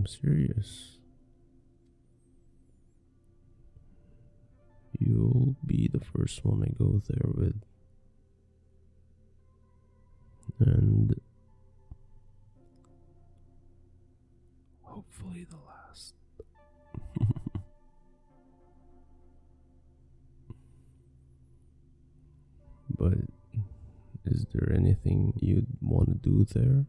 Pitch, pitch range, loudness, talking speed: 100 Hz, 85-120 Hz, -29 LUFS, 50 wpm